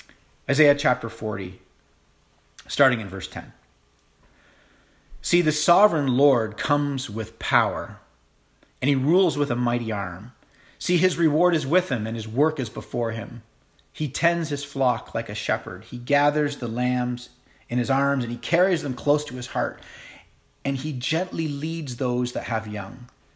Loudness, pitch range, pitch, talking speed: -24 LUFS, 120-150 Hz, 130 Hz, 160 wpm